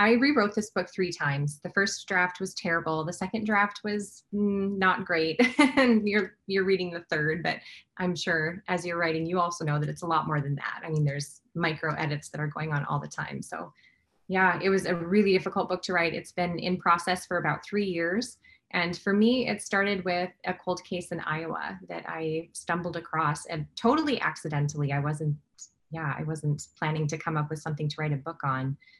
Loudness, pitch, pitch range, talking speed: -28 LUFS, 175 Hz, 155-195 Hz, 215 wpm